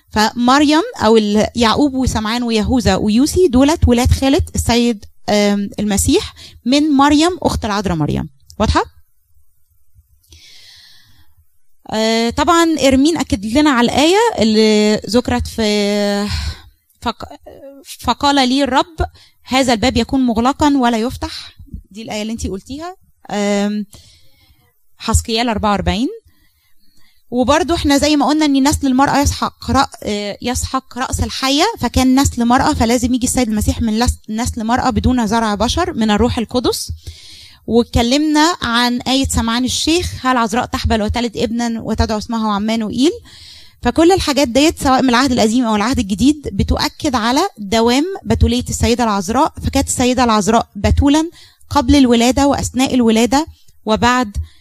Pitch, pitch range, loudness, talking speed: 240 Hz, 215-275 Hz, -15 LUFS, 120 wpm